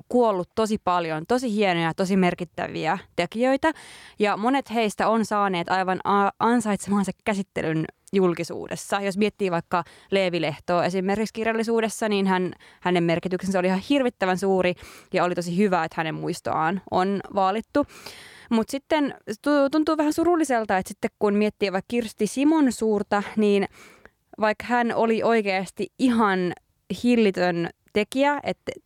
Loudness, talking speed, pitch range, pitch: -24 LUFS, 130 wpm, 185-230 Hz, 205 Hz